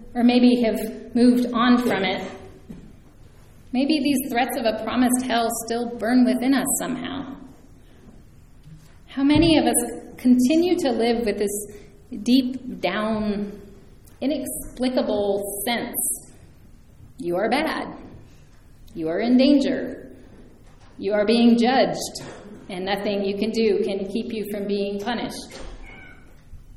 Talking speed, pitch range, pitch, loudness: 120 wpm, 210-255 Hz, 235 Hz, -22 LUFS